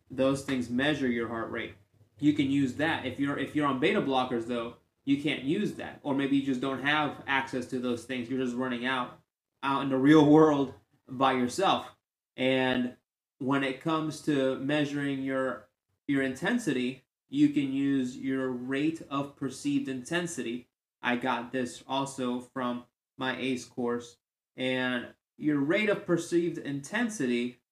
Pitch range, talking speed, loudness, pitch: 125-145 Hz, 160 wpm, -29 LUFS, 135 Hz